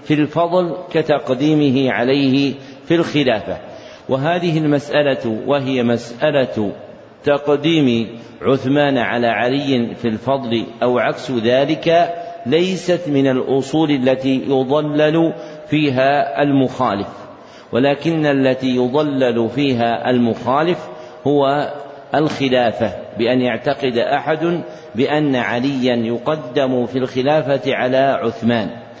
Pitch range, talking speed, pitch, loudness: 125-150 Hz, 90 wpm, 135 Hz, -17 LUFS